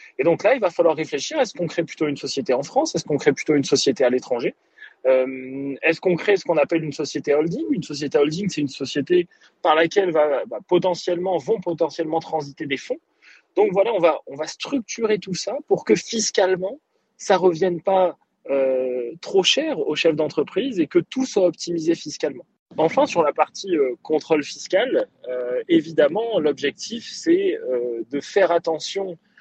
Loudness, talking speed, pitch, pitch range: -21 LUFS, 185 wpm, 170 Hz, 150-225 Hz